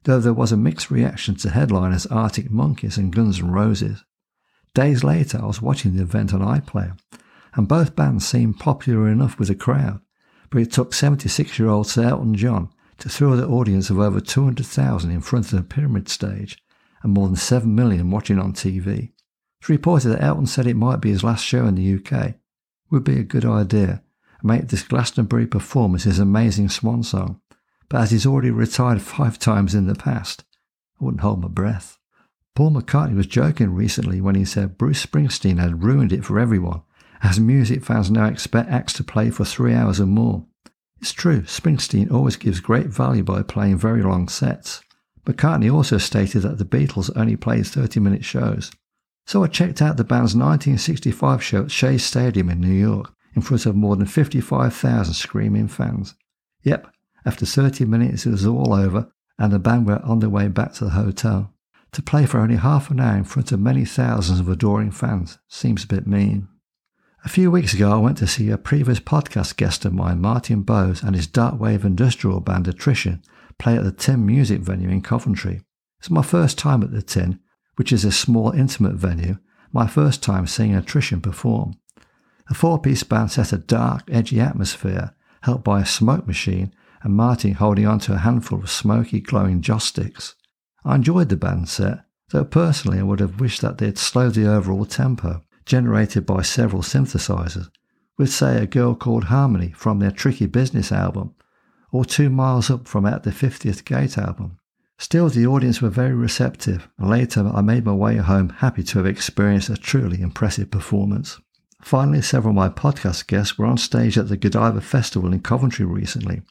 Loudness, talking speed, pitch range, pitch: -19 LUFS, 190 wpm, 100-125 Hz, 110 Hz